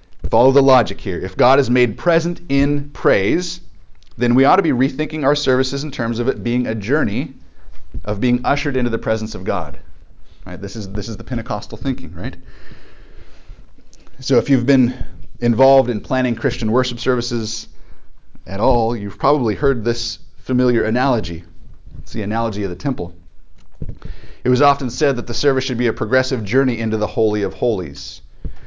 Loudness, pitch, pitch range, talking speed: -18 LUFS, 120 Hz, 100-130 Hz, 175 wpm